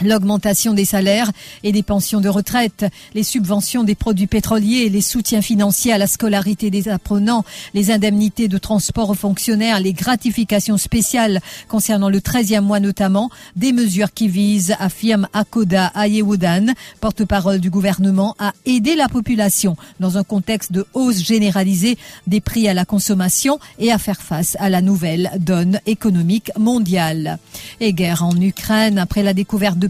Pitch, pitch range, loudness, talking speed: 205 Hz, 195-220 Hz, -16 LUFS, 160 wpm